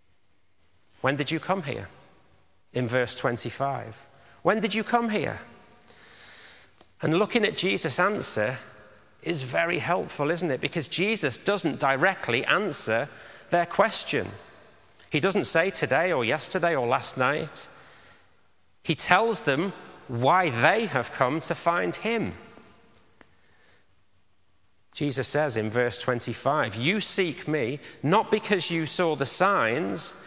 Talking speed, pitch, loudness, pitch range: 125 wpm, 145 Hz, -25 LUFS, 120-180 Hz